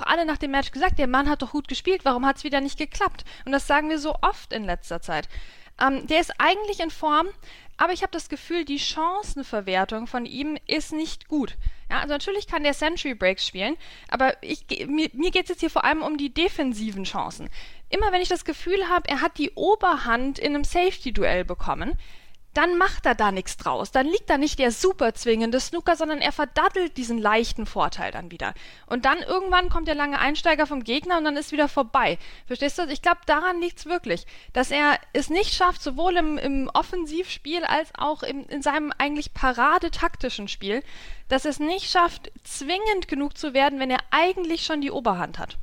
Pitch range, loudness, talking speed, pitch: 265-340 Hz, -24 LUFS, 205 wpm, 295 Hz